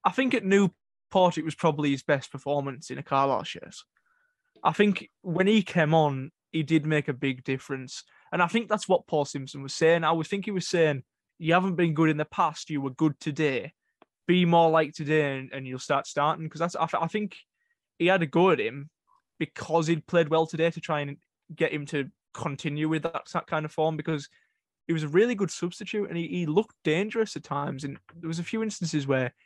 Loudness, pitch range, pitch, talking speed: -27 LUFS, 145-180 Hz, 160 Hz, 220 wpm